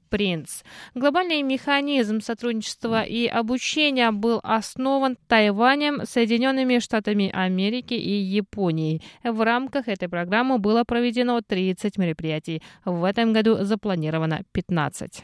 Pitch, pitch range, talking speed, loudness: 225 Hz, 190-245 Hz, 105 wpm, -23 LUFS